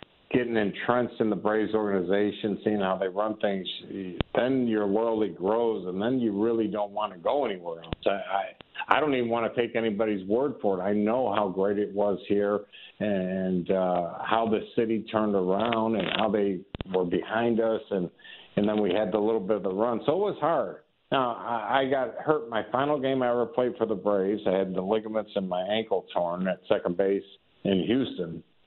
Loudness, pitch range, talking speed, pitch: -27 LUFS, 100-115 Hz, 205 wpm, 105 Hz